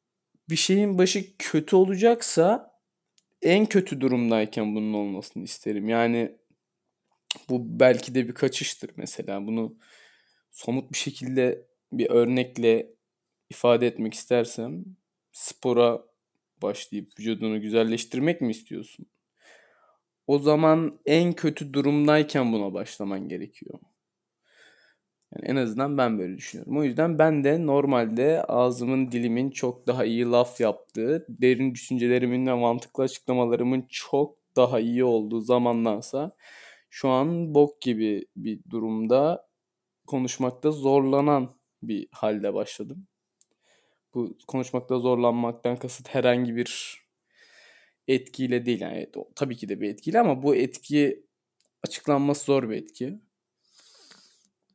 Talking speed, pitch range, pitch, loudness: 110 wpm, 120-145 Hz, 125 Hz, -25 LUFS